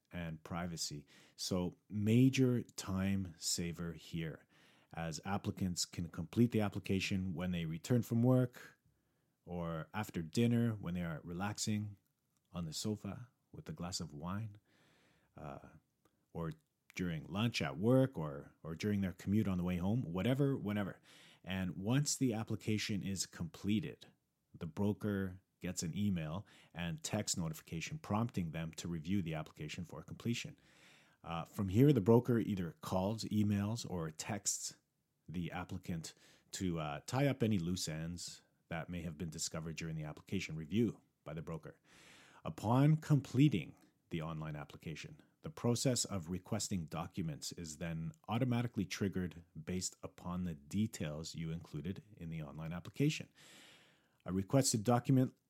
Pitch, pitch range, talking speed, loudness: 95 Hz, 85-120 Hz, 140 wpm, -38 LUFS